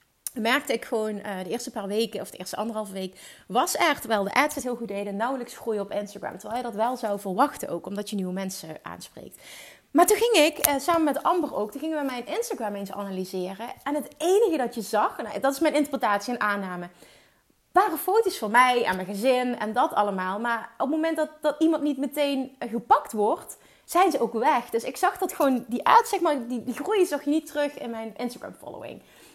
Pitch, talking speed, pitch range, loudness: 245 Hz, 225 wpm, 210-295 Hz, -26 LUFS